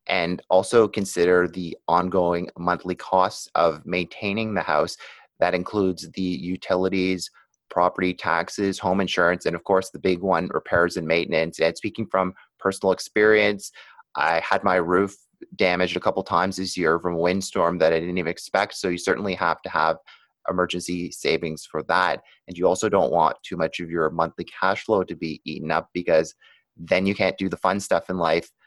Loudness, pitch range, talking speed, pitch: -23 LUFS, 90-95 Hz, 180 wpm, 90 Hz